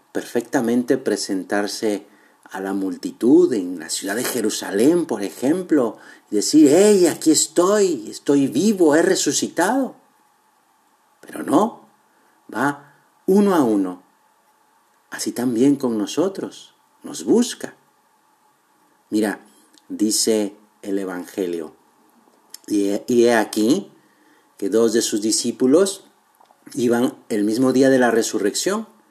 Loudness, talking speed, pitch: -19 LUFS, 105 wpm, 130 Hz